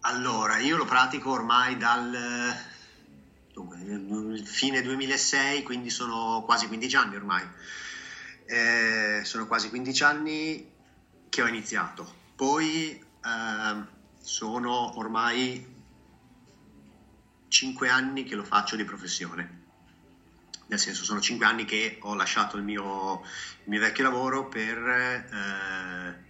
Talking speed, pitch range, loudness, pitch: 115 wpm, 90-125 Hz, -27 LUFS, 110 Hz